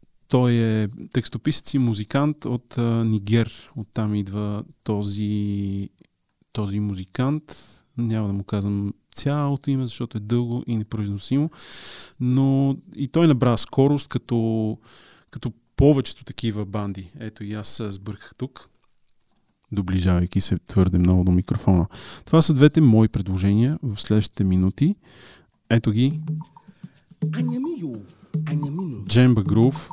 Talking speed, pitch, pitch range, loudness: 115 wpm, 115 Hz, 105-135 Hz, -22 LUFS